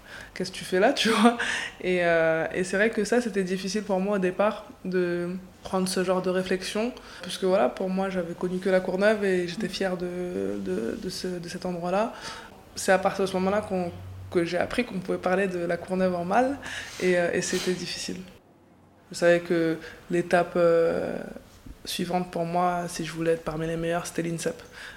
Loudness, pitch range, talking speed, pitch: -26 LUFS, 175-195 Hz, 205 wpm, 185 Hz